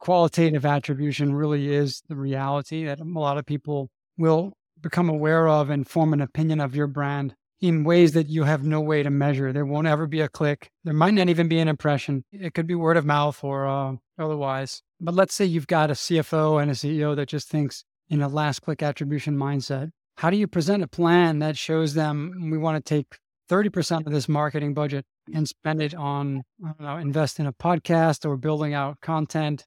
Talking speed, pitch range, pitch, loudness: 210 wpm, 145-165 Hz, 150 Hz, -24 LUFS